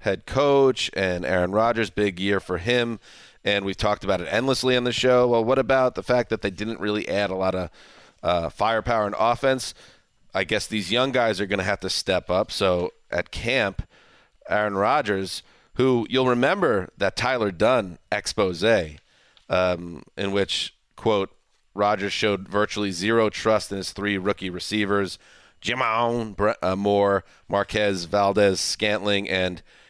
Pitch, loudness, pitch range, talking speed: 105 Hz, -23 LUFS, 95-115 Hz, 160 wpm